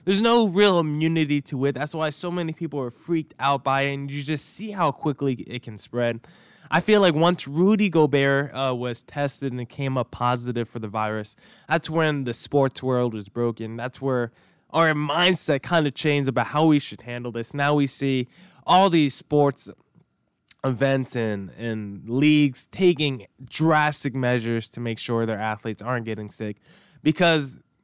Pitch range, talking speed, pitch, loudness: 120-160 Hz, 180 wpm, 140 Hz, -23 LUFS